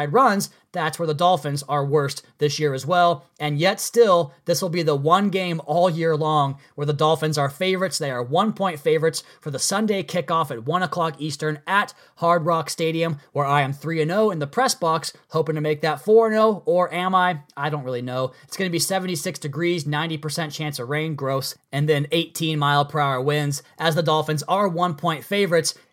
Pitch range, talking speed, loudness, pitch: 150-180 Hz, 215 wpm, -22 LUFS, 160 Hz